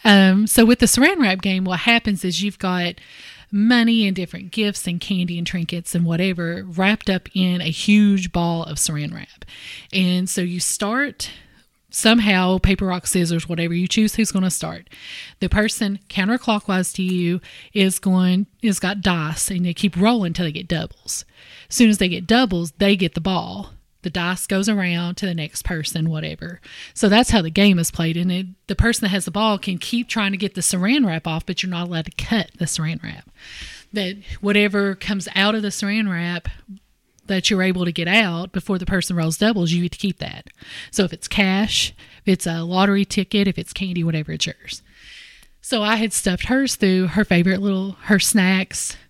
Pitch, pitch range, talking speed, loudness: 190 Hz, 175-205 Hz, 205 wpm, -19 LUFS